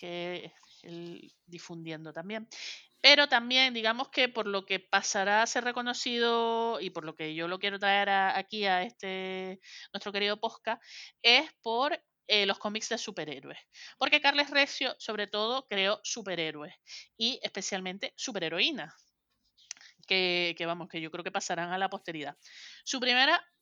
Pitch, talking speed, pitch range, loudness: 200 Hz, 150 wpm, 180-235 Hz, -29 LUFS